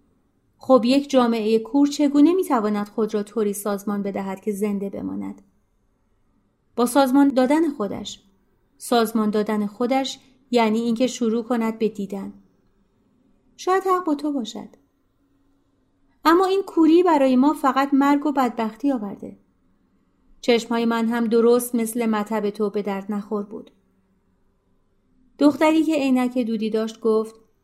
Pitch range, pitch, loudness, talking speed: 205-265 Hz, 225 Hz, -21 LUFS, 130 wpm